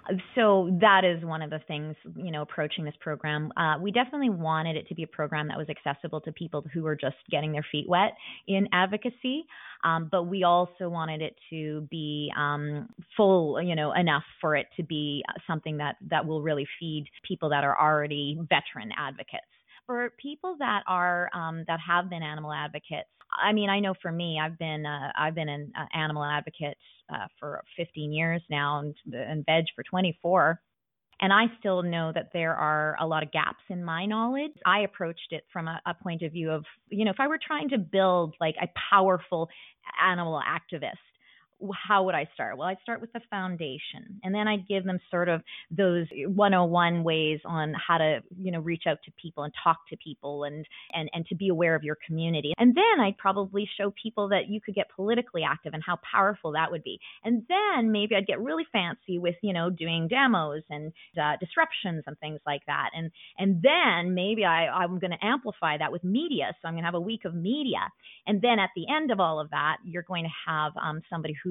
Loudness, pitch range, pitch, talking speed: -28 LUFS, 155-195 Hz, 170 Hz, 210 wpm